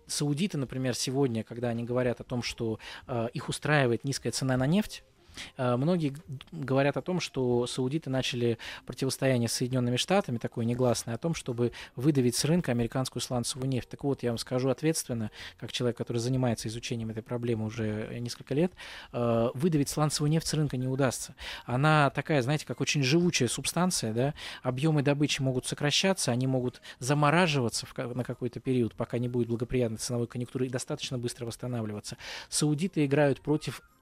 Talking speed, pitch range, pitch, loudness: 160 wpm, 120-145 Hz, 130 Hz, -30 LUFS